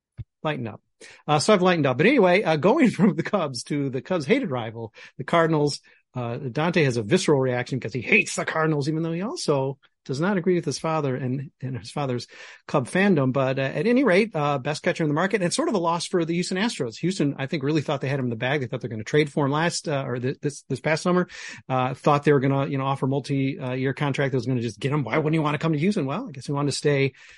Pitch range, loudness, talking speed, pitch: 135-175 Hz, -24 LUFS, 285 wpm, 150 Hz